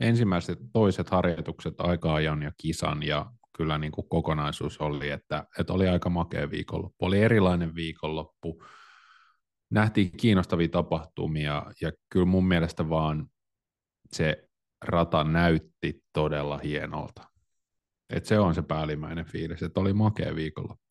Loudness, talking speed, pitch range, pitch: -28 LUFS, 125 wpm, 80-90 Hz, 85 Hz